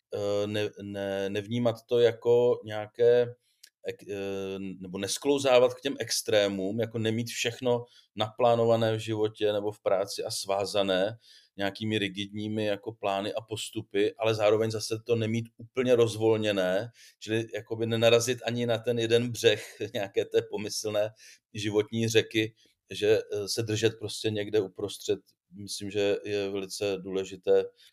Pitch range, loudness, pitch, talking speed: 105-120 Hz, -28 LUFS, 110 Hz, 125 wpm